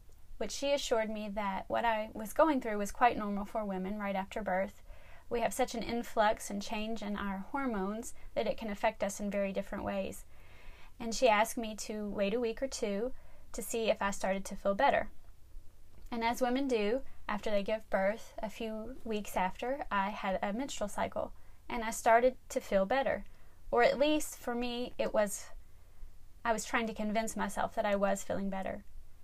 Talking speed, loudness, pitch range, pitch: 195 wpm, -34 LUFS, 200-240 Hz, 215 Hz